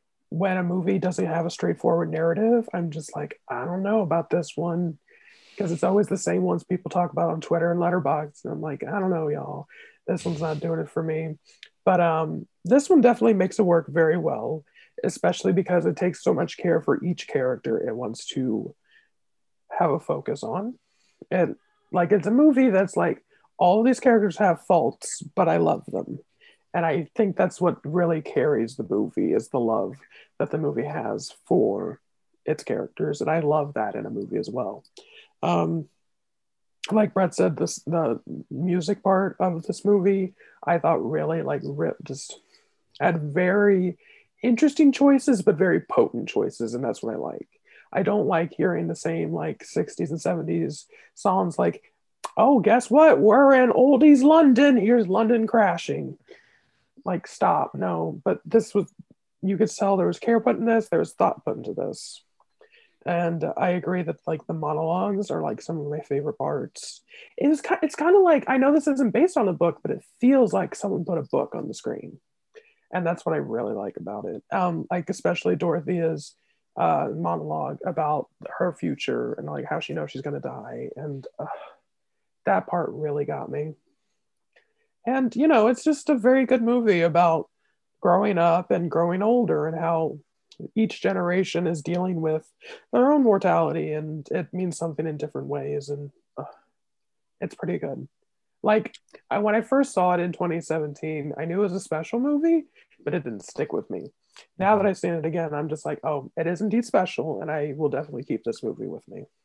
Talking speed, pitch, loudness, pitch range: 185 wpm, 185 Hz, -24 LUFS, 165-240 Hz